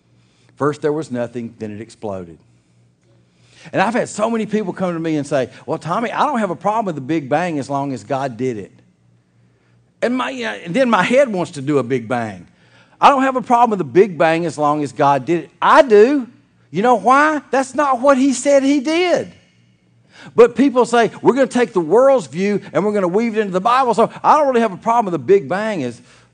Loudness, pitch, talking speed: -16 LUFS, 175 Hz, 240 wpm